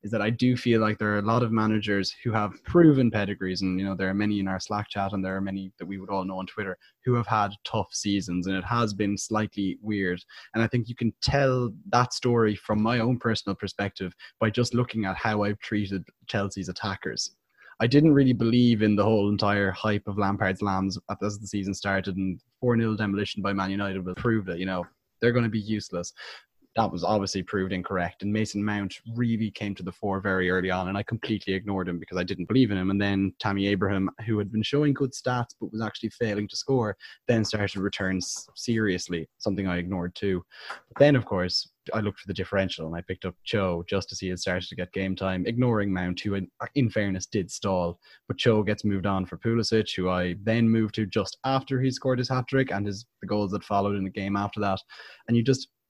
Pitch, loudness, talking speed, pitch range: 100 Hz, -27 LUFS, 235 wpm, 95-115 Hz